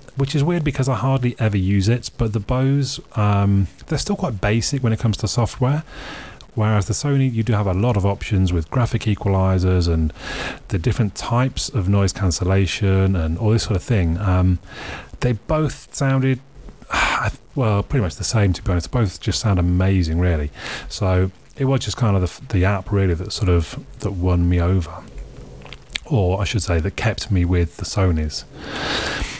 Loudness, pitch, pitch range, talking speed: -20 LUFS, 100 Hz, 90-120 Hz, 185 wpm